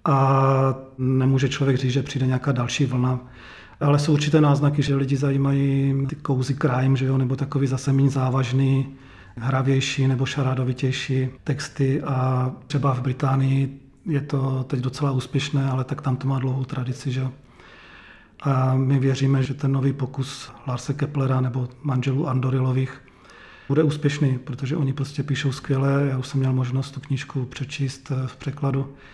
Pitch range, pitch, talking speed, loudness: 130-140 Hz, 135 Hz, 150 wpm, -23 LUFS